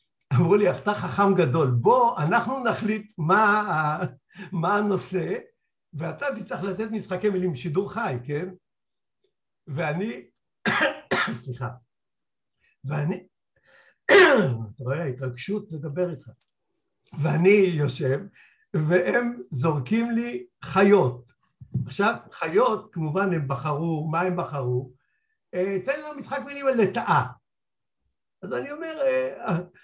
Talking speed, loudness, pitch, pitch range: 100 wpm, -24 LUFS, 180 Hz, 145-215 Hz